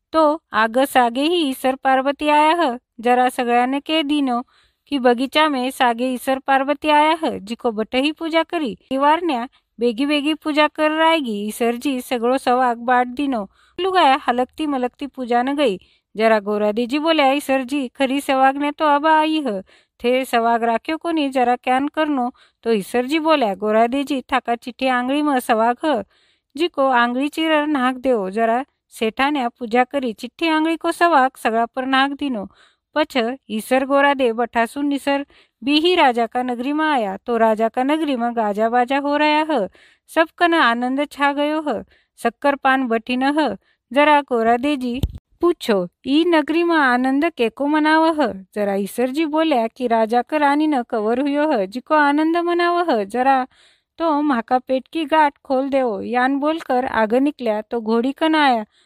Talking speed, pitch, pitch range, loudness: 165 wpm, 265 Hz, 240-300 Hz, -19 LUFS